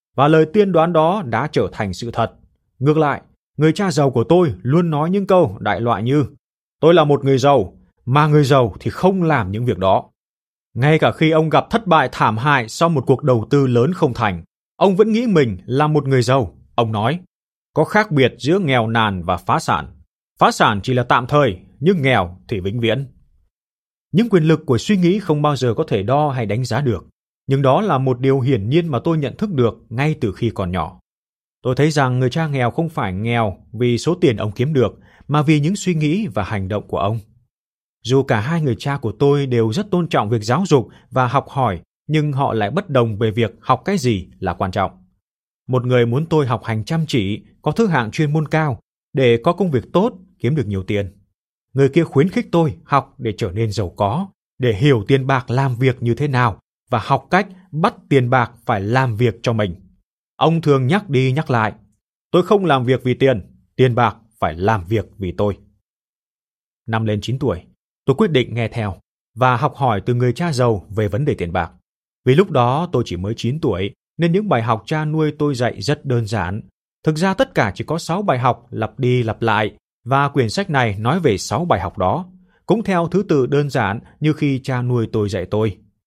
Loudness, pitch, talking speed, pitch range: -18 LUFS, 130 Hz, 225 wpm, 110-155 Hz